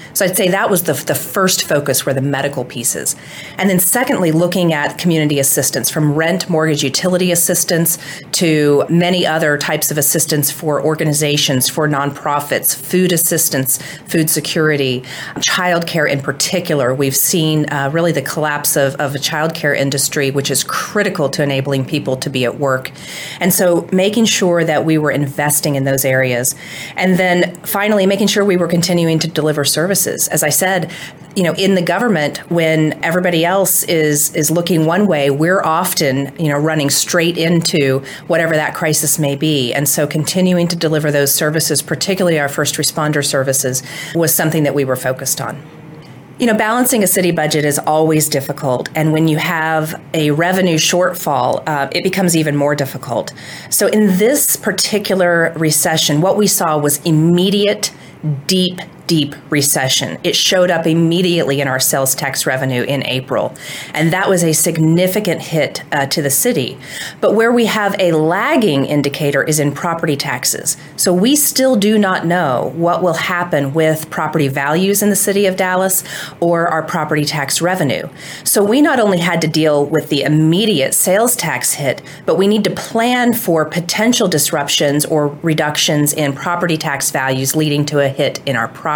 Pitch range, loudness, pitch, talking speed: 145-180 Hz, -14 LUFS, 155 Hz, 170 wpm